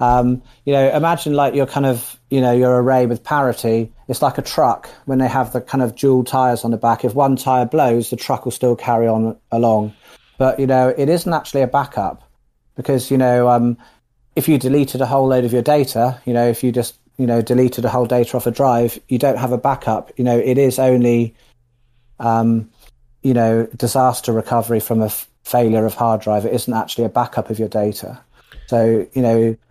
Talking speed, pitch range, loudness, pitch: 220 wpm, 115-130 Hz, -17 LUFS, 125 Hz